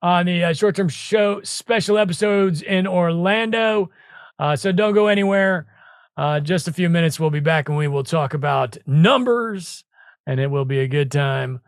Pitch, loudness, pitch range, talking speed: 175 Hz, -19 LUFS, 150-200 Hz, 180 wpm